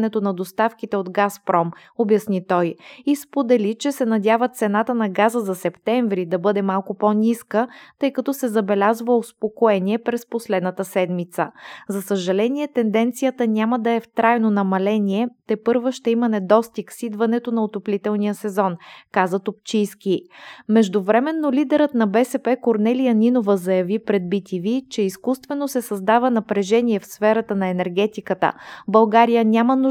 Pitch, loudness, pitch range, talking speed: 220 Hz, -20 LUFS, 200-240 Hz, 140 wpm